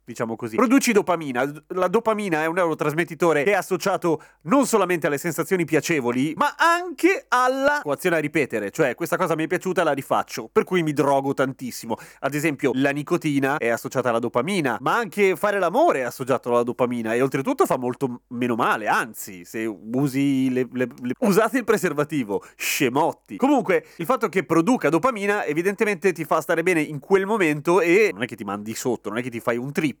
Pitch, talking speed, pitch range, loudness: 165 Hz, 190 wpm, 130-205 Hz, -22 LUFS